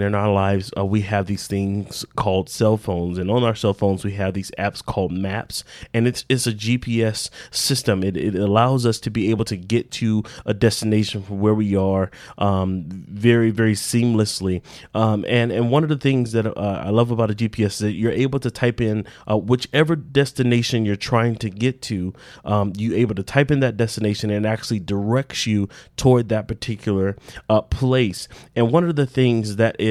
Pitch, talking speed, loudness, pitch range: 110 Hz, 205 wpm, -21 LUFS, 100-120 Hz